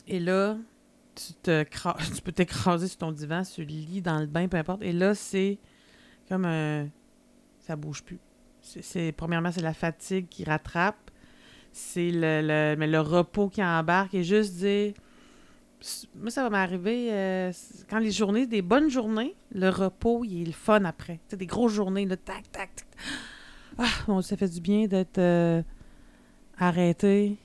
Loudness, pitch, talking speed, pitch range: -28 LUFS, 185 Hz, 175 wpm, 165-205 Hz